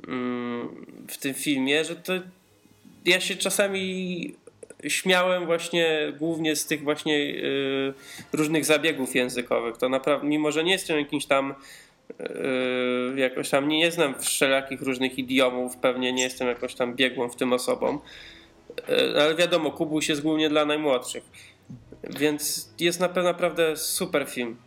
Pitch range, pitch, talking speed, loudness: 130-170 Hz, 150 Hz, 140 wpm, -25 LUFS